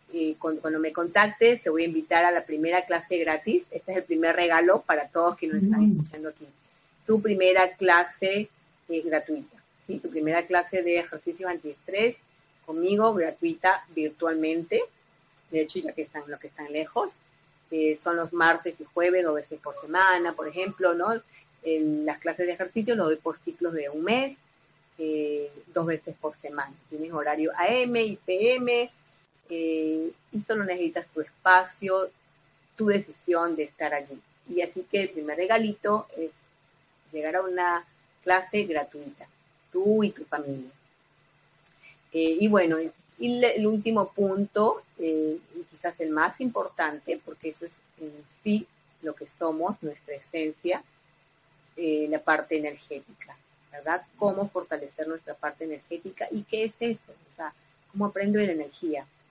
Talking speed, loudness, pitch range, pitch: 155 wpm, -27 LUFS, 155-185 Hz, 165 Hz